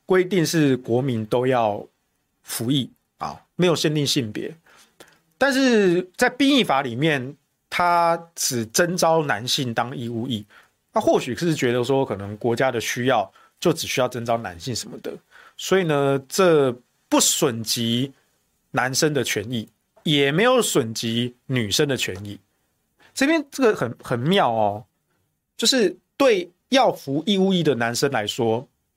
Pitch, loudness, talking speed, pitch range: 140 Hz, -21 LUFS, 210 characters per minute, 120-180 Hz